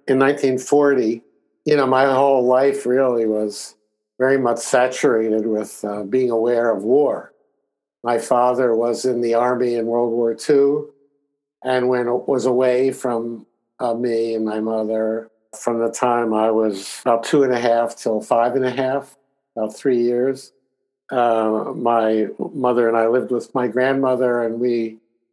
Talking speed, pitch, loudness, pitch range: 160 wpm, 120 Hz, -19 LUFS, 115-130 Hz